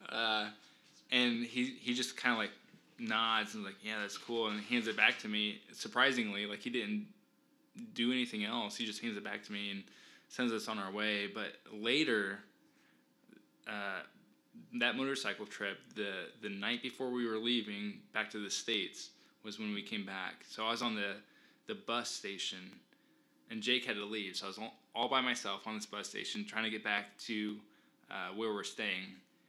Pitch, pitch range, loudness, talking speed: 110 Hz, 105-125 Hz, -37 LUFS, 195 wpm